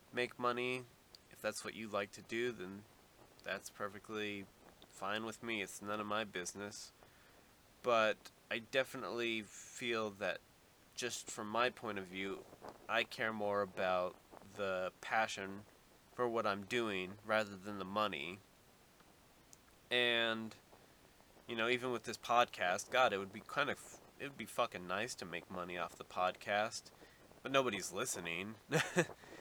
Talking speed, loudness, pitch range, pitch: 145 wpm, -39 LUFS, 100-120 Hz, 110 Hz